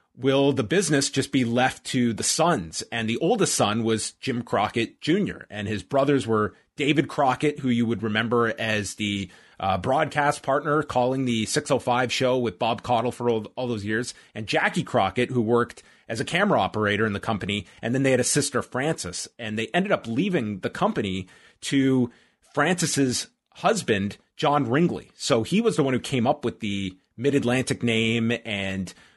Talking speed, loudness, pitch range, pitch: 185 wpm, -24 LUFS, 110-135 Hz, 120 Hz